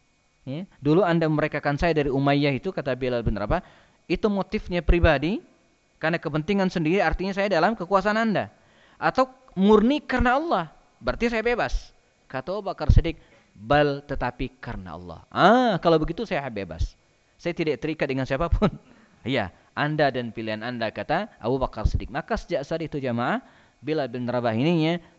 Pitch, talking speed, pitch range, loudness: 155 Hz, 155 wpm, 125-185 Hz, -24 LUFS